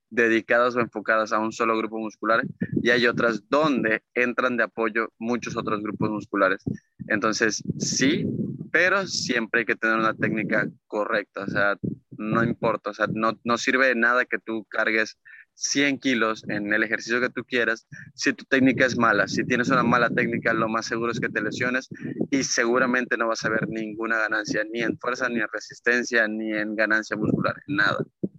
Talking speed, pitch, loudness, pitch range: 185 wpm, 115 Hz, -24 LUFS, 110-125 Hz